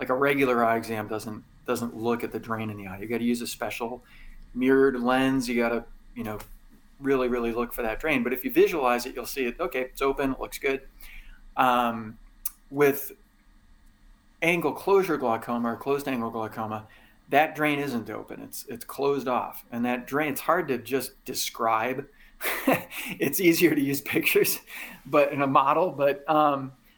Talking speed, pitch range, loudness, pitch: 185 wpm, 115-140 Hz, -26 LUFS, 125 Hz